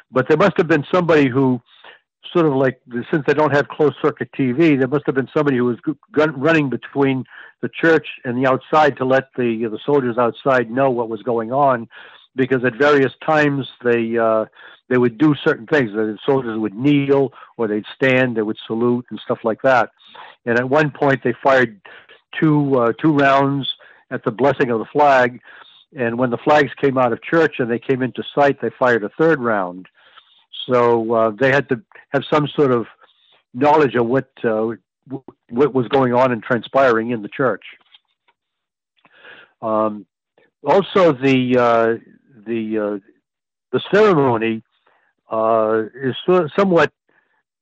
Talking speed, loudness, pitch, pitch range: 170 wpm, -17 LUFS, 130 Hz, 115-145 Hz